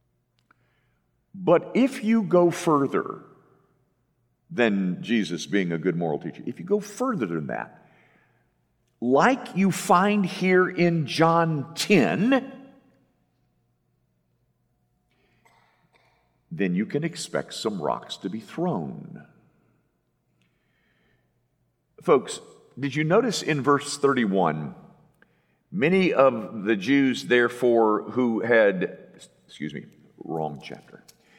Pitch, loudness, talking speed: 150 Hz, -23 LUFS, 100 wpm